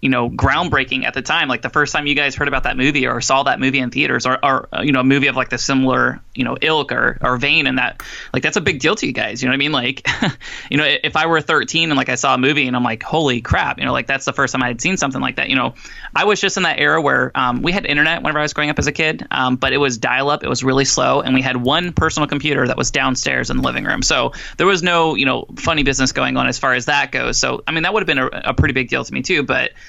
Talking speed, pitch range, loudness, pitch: 320 wpm, 130-150 Hz, -16 LUFS, 135 Hz